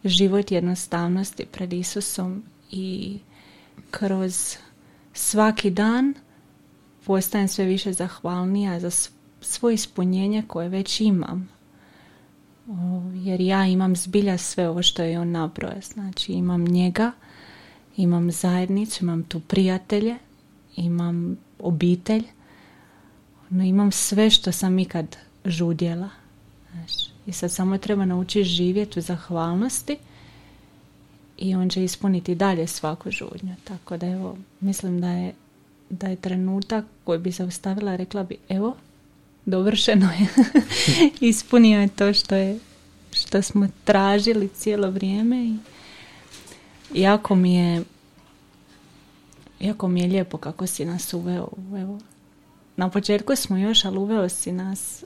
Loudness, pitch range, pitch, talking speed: -23 LUFS, 180-205 Hz, 190 Hz, 120 wpm